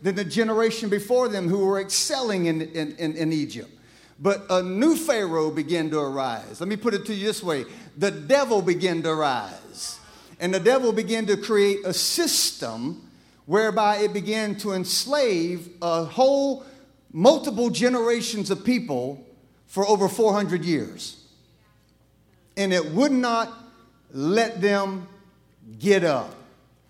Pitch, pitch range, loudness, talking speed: 200 Hz, 175-230 Hz, -23 LUFS, 145 wpm